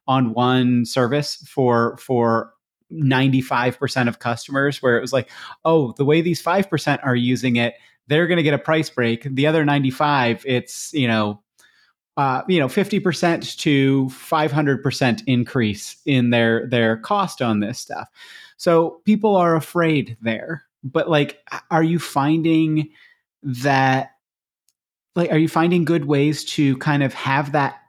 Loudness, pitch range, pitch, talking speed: -19 LUFS, 125-160 Hz, 140 Hz, 165 wpm